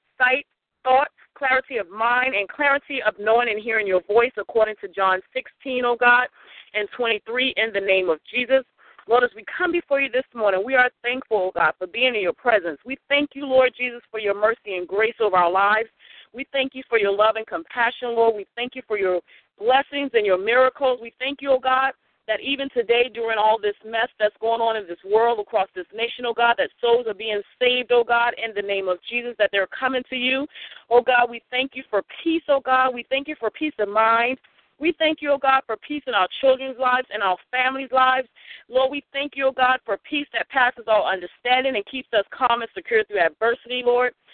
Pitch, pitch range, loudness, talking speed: 240 Hz, 215-260 Hz, -21 LUFS, 235 wpm